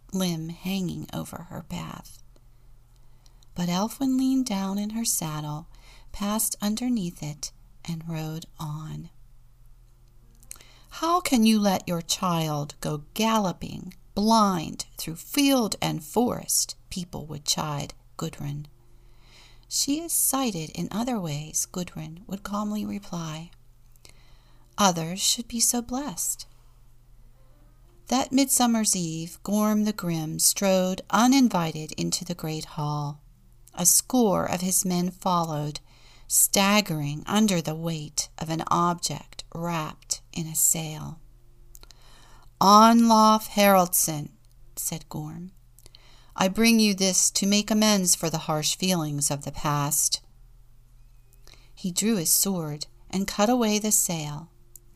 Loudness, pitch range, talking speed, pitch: -24 LUFS, 125-200 Hz, 115 wpm, 160 Hz